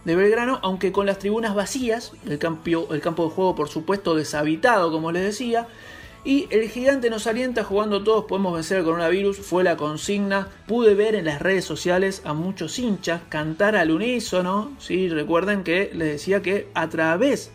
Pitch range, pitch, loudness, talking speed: 165-215 Hz, 190 Hz, -22 LUFS, 190 wpm